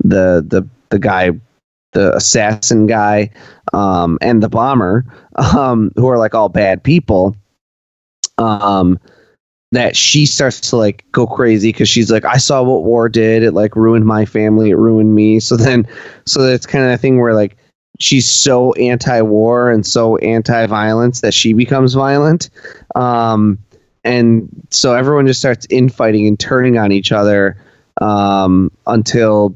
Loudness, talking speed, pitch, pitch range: -11 LUFS, 160 wpm, 115 Hz, 105-125 Hz